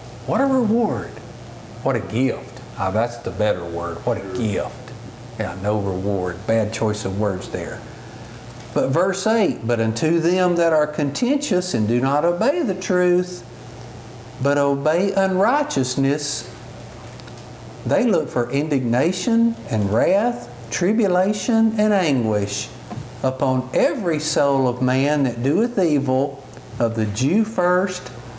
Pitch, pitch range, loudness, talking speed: 125 Hz, 115-170 Hz, -20 LUFS, 130 wpm